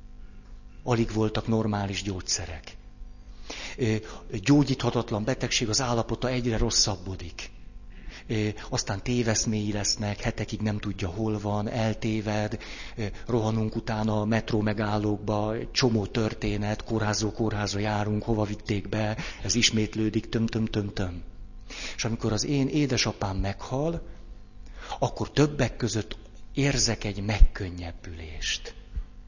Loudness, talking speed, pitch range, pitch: -28 LUFS, 95 wpm, 105-115 Hz, 110 Hz